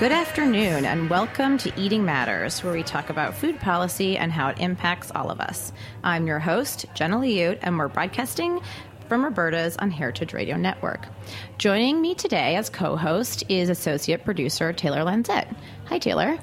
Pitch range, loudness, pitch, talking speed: 150-215 Hz, -24 LUFS, 175 Hz, 170 wpm